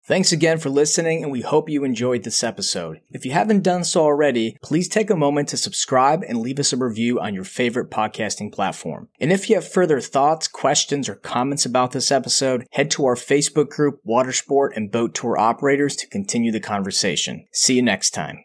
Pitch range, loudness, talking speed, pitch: 125-160 Hz, -20 LUFS, 205 wpm, 140 Hz